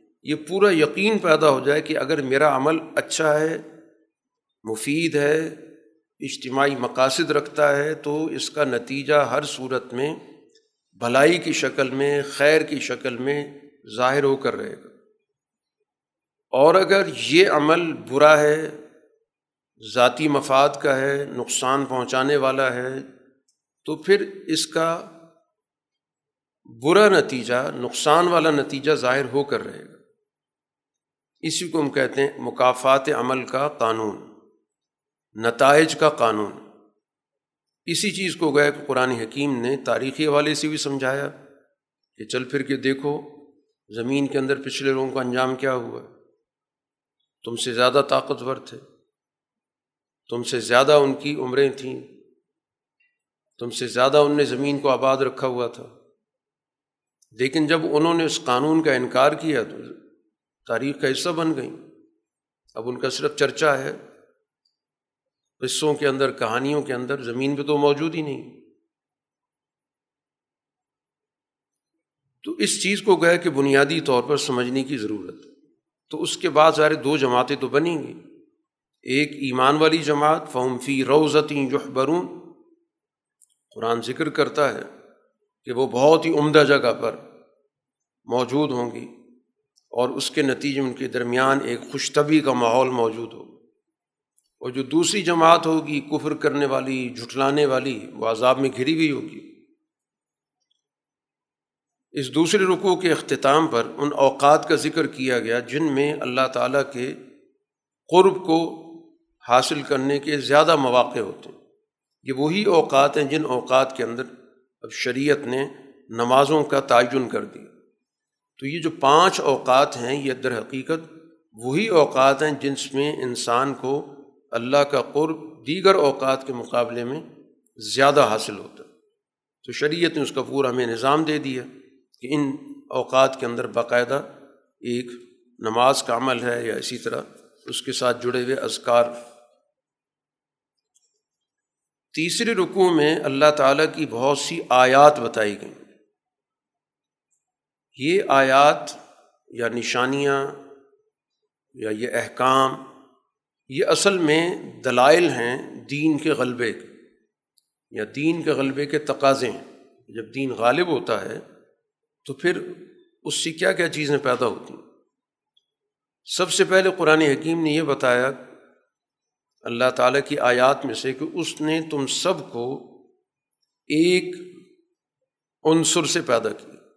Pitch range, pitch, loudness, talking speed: 130-160 Hz, 145 Hz, -21 LUFS, 140 wpm